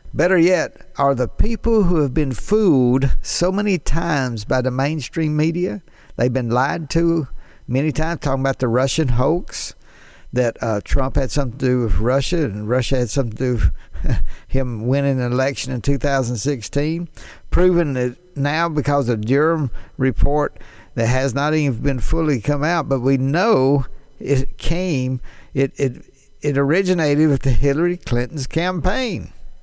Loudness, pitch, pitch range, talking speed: -19 LUFS, 140 Hz, 125-160 Hz, 155 wpm